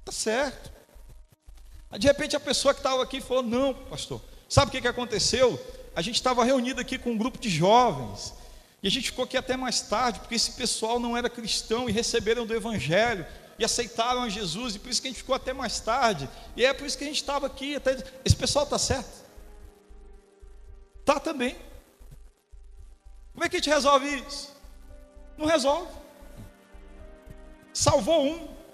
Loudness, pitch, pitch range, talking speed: -26 LUFS, 250 Hz, 225-280 Hz, 180 wpm